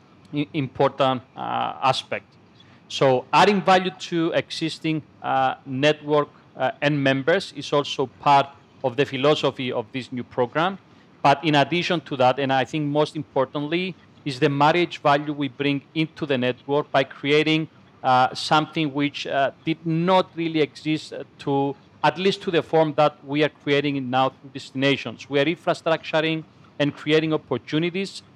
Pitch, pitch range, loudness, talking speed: 145 Hz, 135-160 Hz, -23 LUFS, 150 wpm